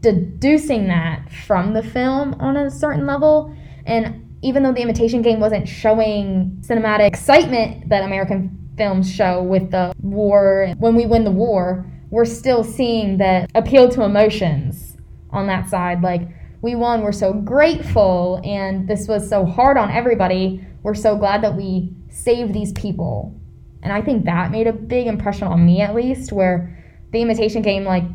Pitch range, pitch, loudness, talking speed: 185-230 Hz, 205 Hz, -17 LUFS, 170 wpm